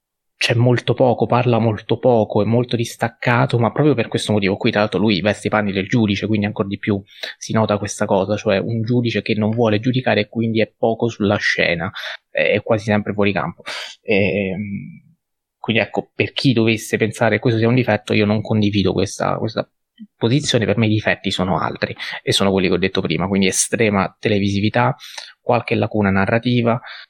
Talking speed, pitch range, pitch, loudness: 190 wpm, 105-115 Hz, 110 Hz, -18 LUFS